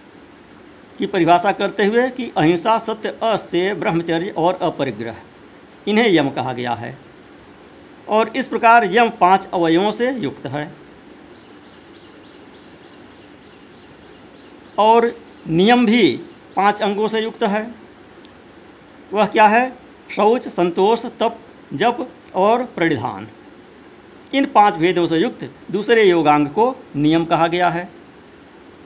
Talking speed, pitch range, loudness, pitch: 110 wpm, 170-230 Hz, -17 LUFS, 205 Hz